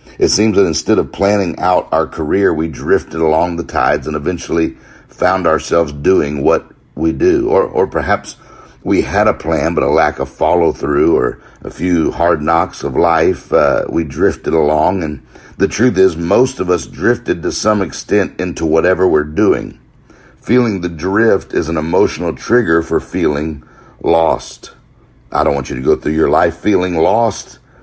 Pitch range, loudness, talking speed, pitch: 80-125 Hz, -14 LUFS, 175 wpm, 90 Hz